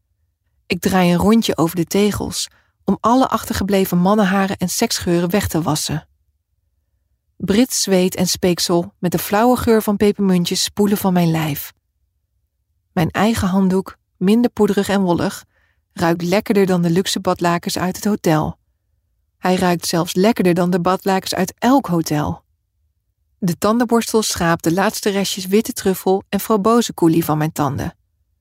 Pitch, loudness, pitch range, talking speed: 180 Hz, -17 LUFS, 150-205 Hz, 150 wpm